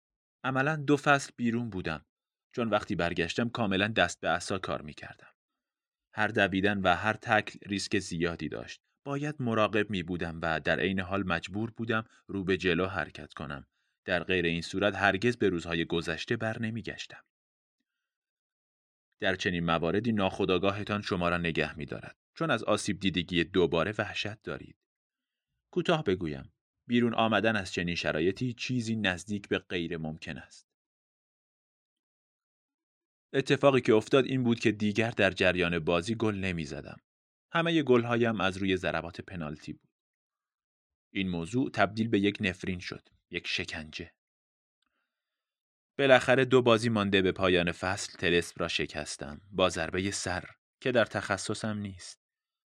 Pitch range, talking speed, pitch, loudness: 85-115 Hz, 140 wpm, 100 Hz, -29 LUFS